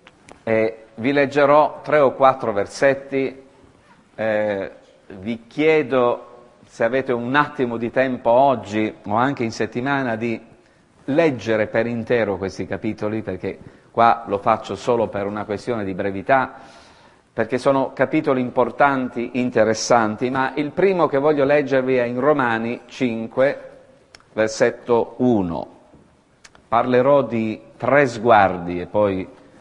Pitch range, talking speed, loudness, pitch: 110-135 Hz, 120 wpm, -20 LUFS, 120 Hz